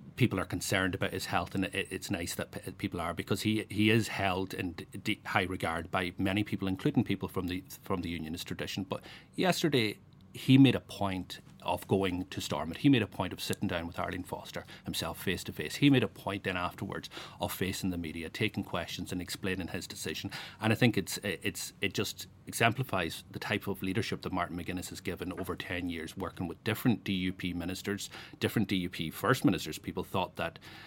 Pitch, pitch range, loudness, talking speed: 95 Hz, 90-105 Hz, -33 LUFS, 200 wpm